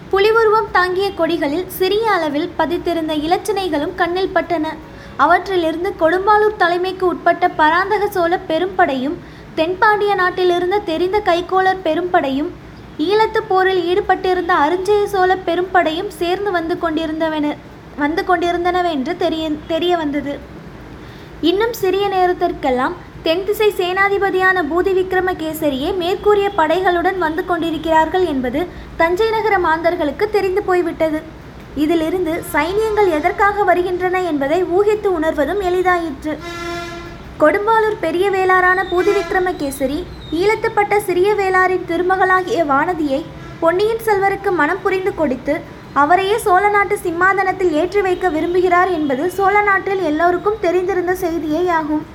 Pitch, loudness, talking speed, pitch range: 360 Hz, -16 LUFS, 100 wpm, 325-385 Hz